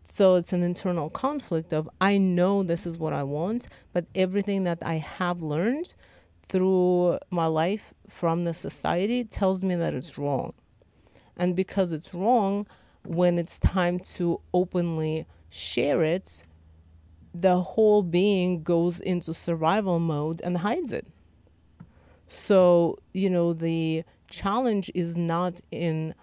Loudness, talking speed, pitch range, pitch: -26 LUFS, 135 wpm, 165-190 Hz, 175 Hz